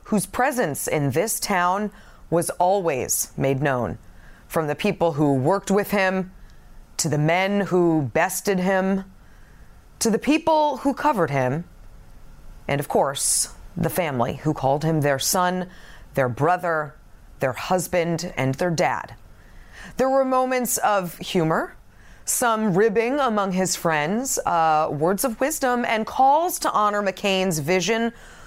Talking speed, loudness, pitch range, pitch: 135 wpm, -22 LUFS, 155-215 Hz, 185 Hz